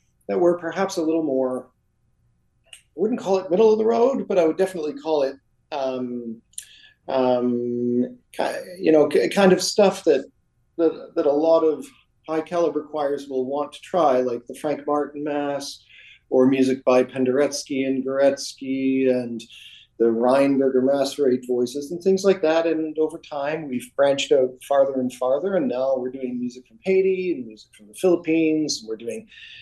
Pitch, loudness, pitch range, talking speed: 140 Hz, -22 LUFS, 125-165 Hz, 175 wpm